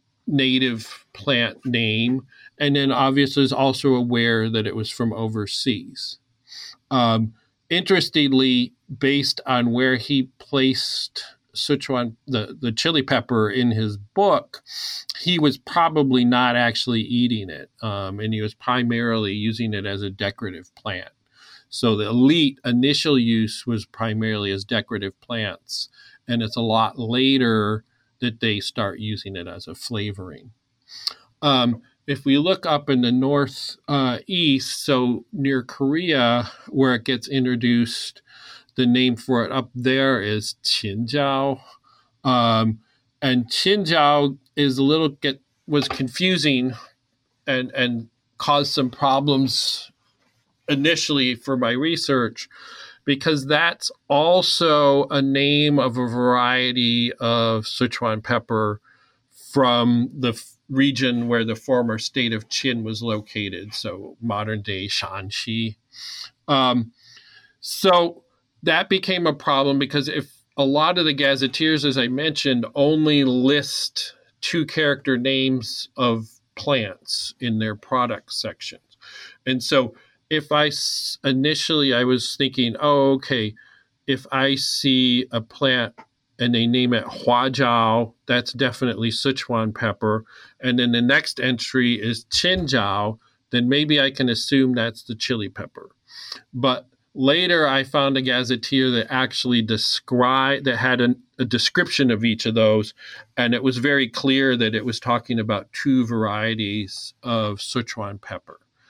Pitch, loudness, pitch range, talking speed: 125 Hz, -21 LUFS, 115-140 Hz, 130 wpm